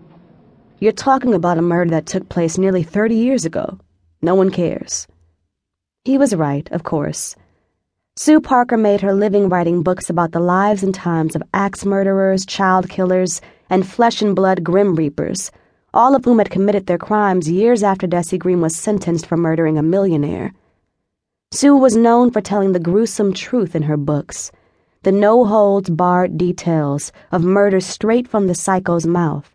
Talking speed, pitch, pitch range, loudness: 170 wpm, 185 Hz, 170-205 Hz, -16 LUFS